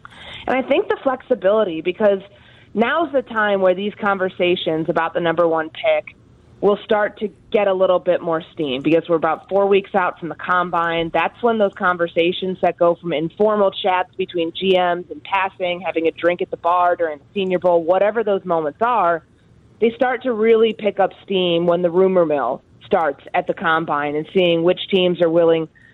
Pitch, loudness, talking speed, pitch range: 180 Hz, -19 LUFS, 190 wpm, 170-200 Hz